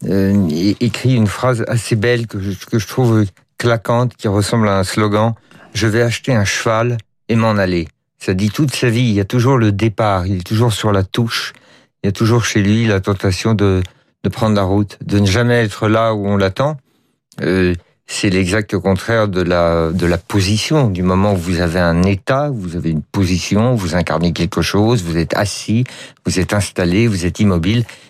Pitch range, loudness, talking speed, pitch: 95-115 Hz, -16 LUFS, 205 wpm, 105 Hz